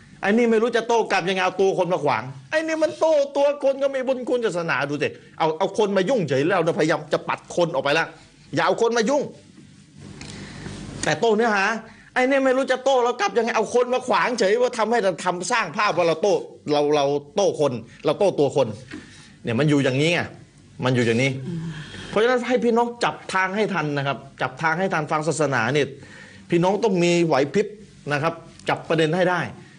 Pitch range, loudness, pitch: 150-230 Hz, -22 LUFS, 180 Hz